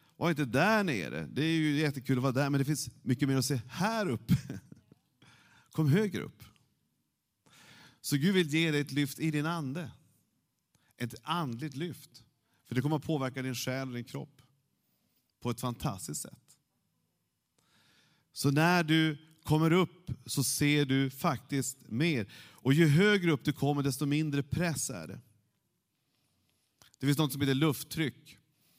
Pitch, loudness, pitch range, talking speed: 145 Hz, -31 LUFS, 130-155 Hz, 160 wpm